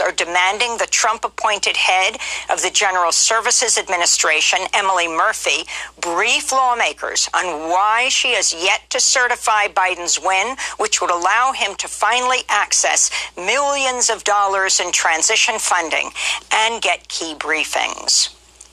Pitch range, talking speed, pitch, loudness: 190-245 Hz, 130 wpm, 220 Hz, -16 LUFS